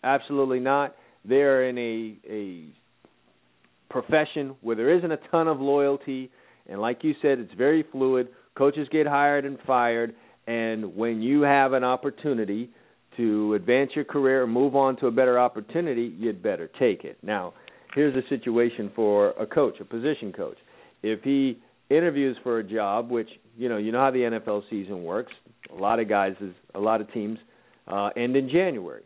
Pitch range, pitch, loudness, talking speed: 110-140 Hz, 125 Hz, -25 LUFS, 180 wpm